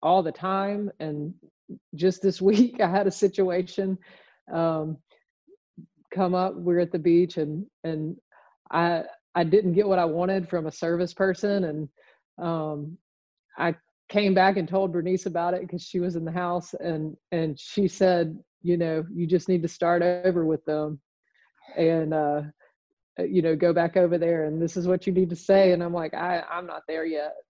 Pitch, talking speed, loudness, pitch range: 175 Hz, 185 wpm, -25 LUFS, 165-190 Hz